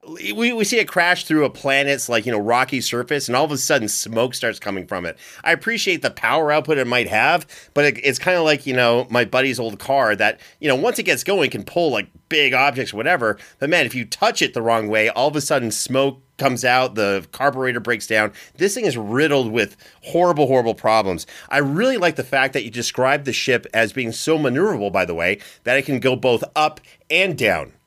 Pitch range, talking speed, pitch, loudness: 120-150 Hz, 235 wpm, 135 Hz, -19 LUFS